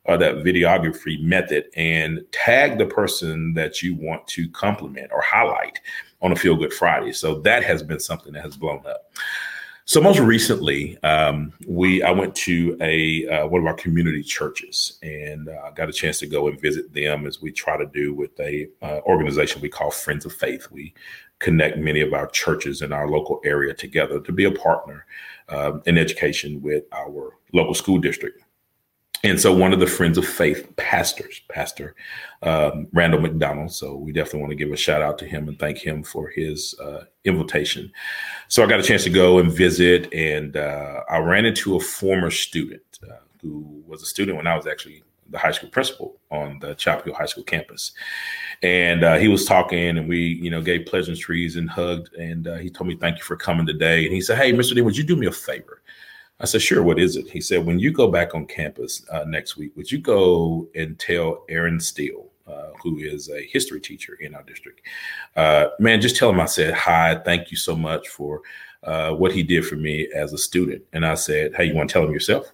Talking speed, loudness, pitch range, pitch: 215 wpm, -20 LUFS, 75-95 Hz, 85 Hz